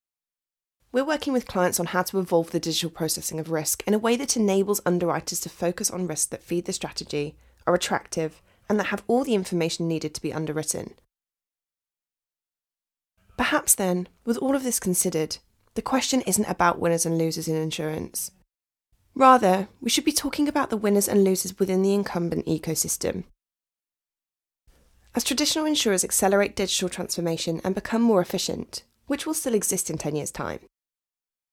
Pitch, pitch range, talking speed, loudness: 185 Hz, 165-225 Hz, 165 wpm, -24 LUFS